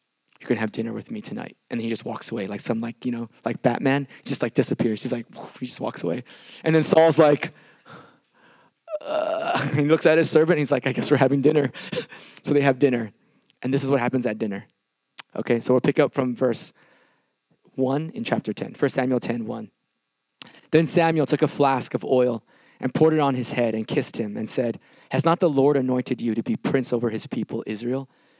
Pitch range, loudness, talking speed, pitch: 120-155 Hz, -23 LUFS, 220 wpm, 135 Hz